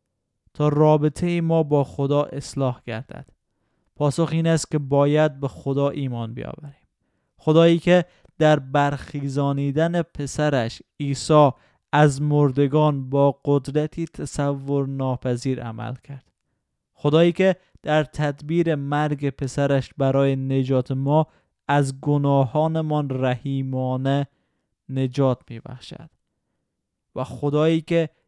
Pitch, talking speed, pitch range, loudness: 145 Hz, 100 wpm, 135-155 Hz, -22 LUFS